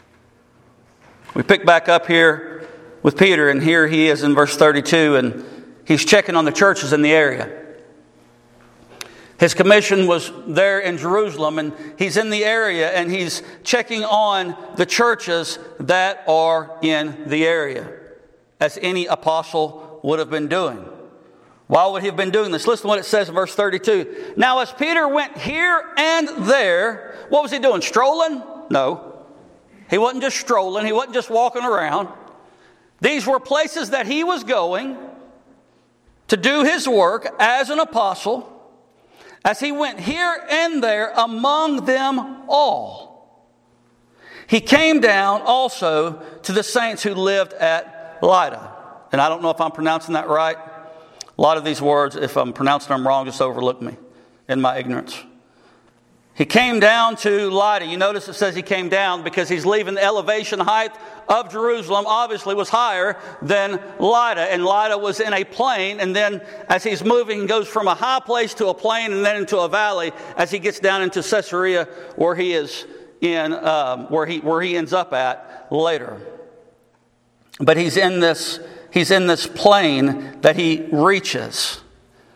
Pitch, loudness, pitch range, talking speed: 195 Hz, -18 LUFS, 160-230 Hz, 165 wpm